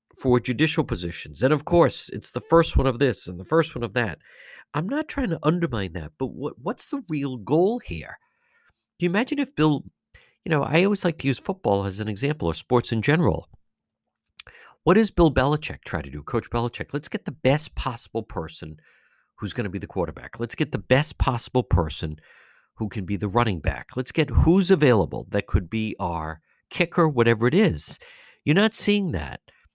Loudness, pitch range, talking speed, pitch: -24 LUFS, 100-165 Hz, 200 wpm, 130 Hz